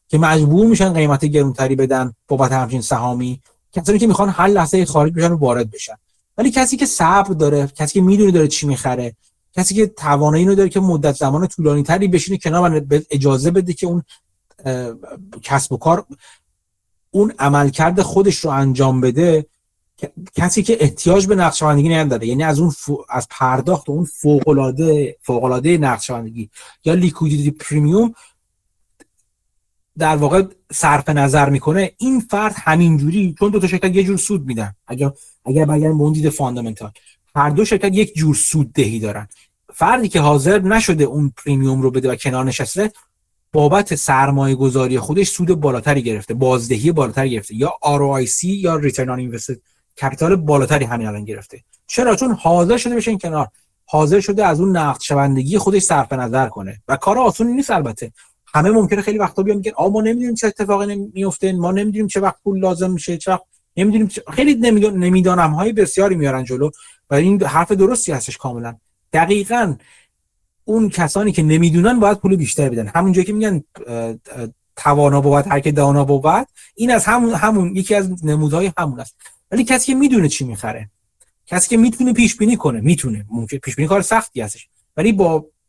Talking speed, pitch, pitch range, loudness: 170 wpm, 155 Hz, 135-195 Hz, -16 LUFS